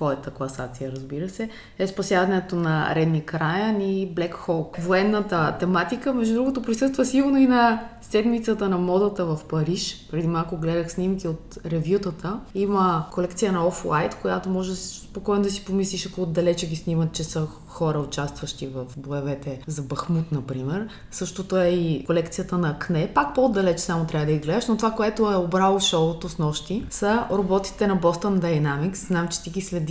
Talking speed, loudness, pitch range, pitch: 175 wpm, -24 LUFS, 160-195 Hz, 180 Hz